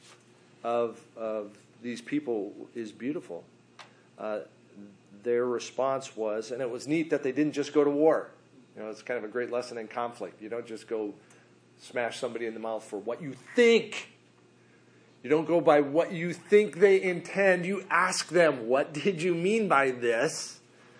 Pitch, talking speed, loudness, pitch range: 120 Hz, 190 wpm, -28 LUFS, 110-160 Hz